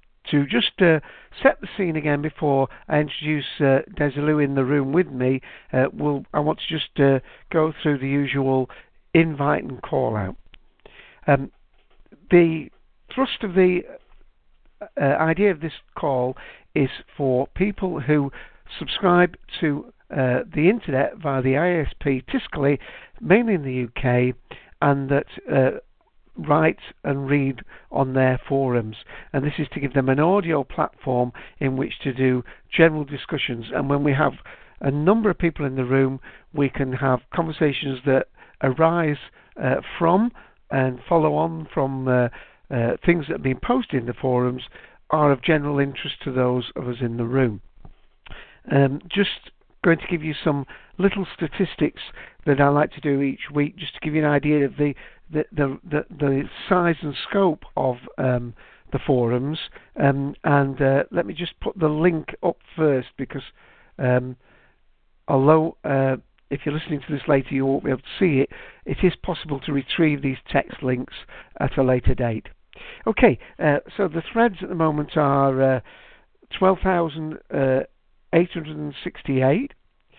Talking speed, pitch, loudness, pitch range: 160 wpm, 145 Hz, -22 LUFS, 135-165 Hz